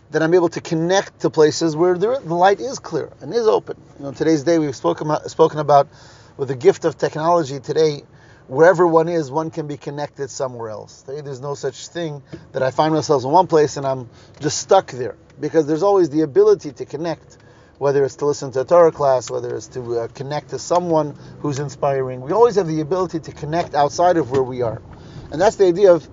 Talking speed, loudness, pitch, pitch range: 225 wpm, -18 LUFS, 155 Hz, 140-170 Hz